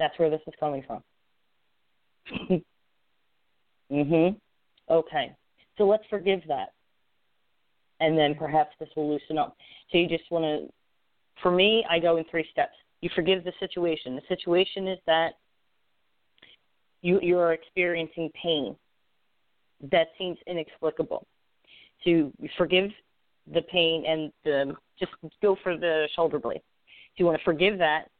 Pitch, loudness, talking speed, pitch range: 165 Hz, -27 LUFS, 140 wpm, 155-180 Hz